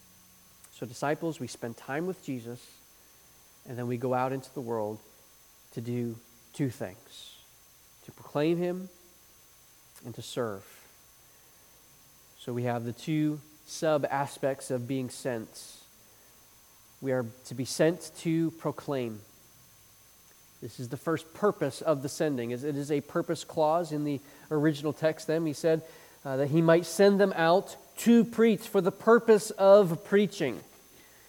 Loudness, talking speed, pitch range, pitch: -29 LUFS, 145 wpm, 125-165 Hz, 145 Hz